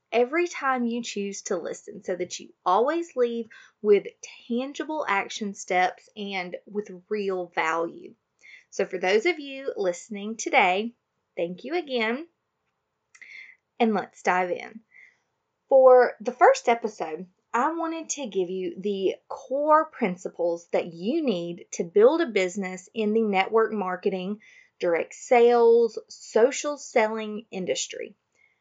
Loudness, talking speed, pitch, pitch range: -25 LUFS, 130 wpm, 235 Hz, 195-315 Hz